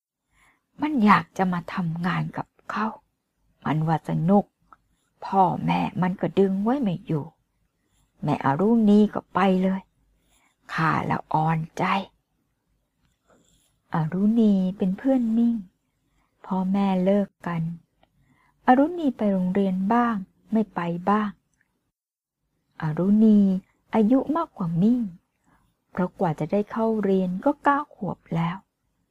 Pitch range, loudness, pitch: 170-215 Hz, -24 LUFS, 190 Hz